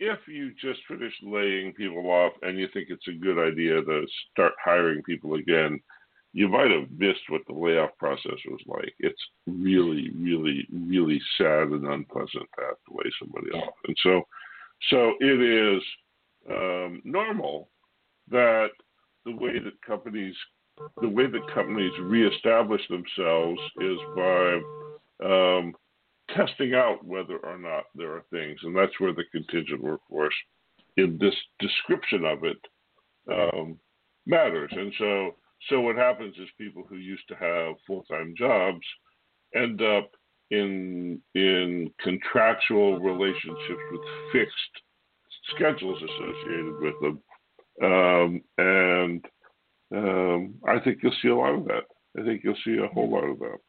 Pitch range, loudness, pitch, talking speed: 85-100 Hz, -26 LUFS, 90 Hz, 145 wpm